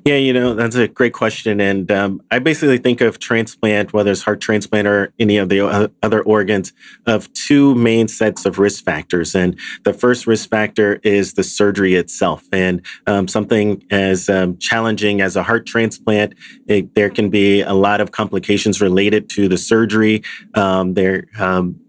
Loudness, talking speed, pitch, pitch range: -16 LUFS, 175 wpm, 105 Hz, 100-110 Hz